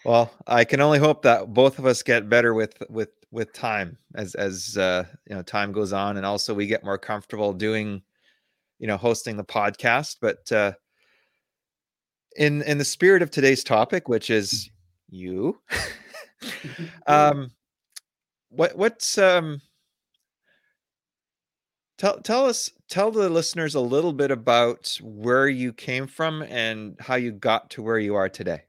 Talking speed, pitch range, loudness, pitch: 155 wpm, 105-150 Hz, -23 LUFS, 120 Hz